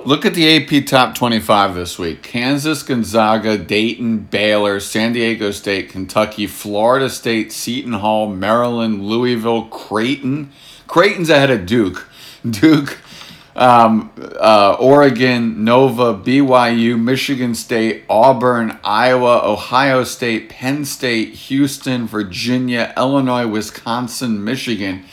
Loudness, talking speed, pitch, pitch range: -15 LUFS, 110 wpm, 120 Hz, 110-130 Hz